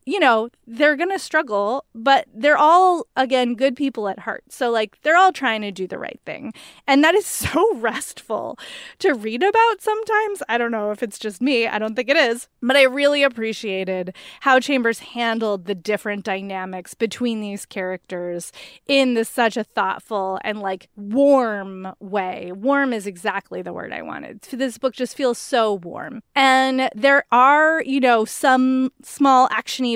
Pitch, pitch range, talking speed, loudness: 245 Hz, 210-275 Hz, 175 wpm, -19 LUFS